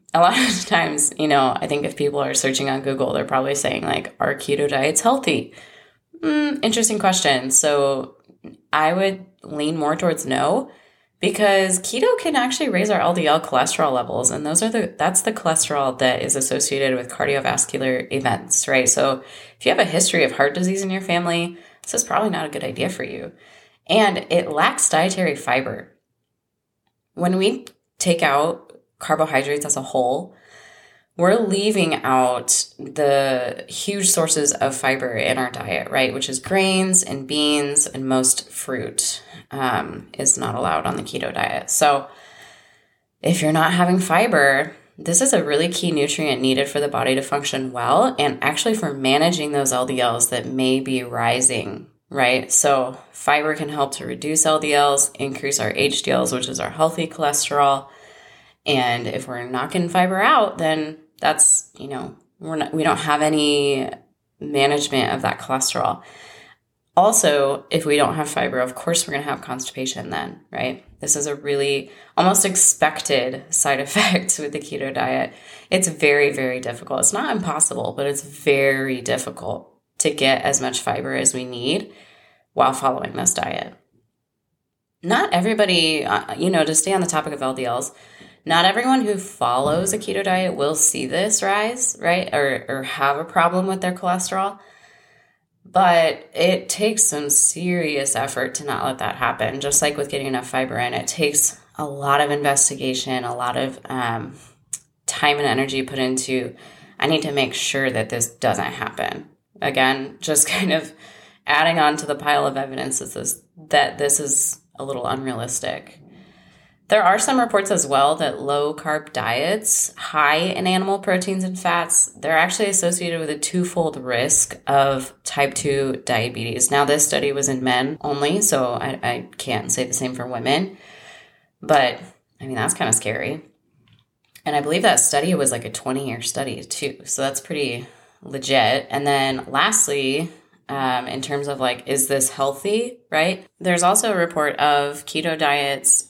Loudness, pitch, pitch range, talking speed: -19 LUFS, 145 Hz, 135-175 Hz, 170 wpm